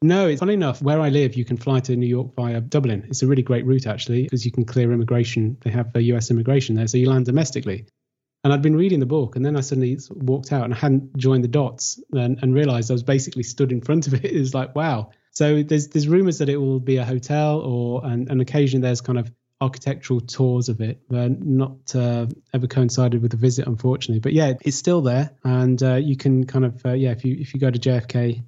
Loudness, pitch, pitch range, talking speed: -21 LUFS, 130 Hz, 125-140 Hz, 250 wpm